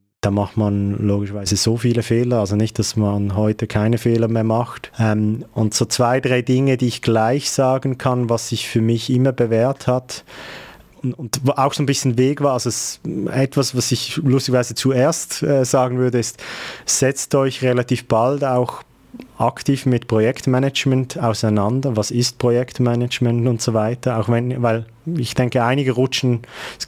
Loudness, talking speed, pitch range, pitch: -19 LUFS, 165 wpm, 115-130 Hz, 125 Hz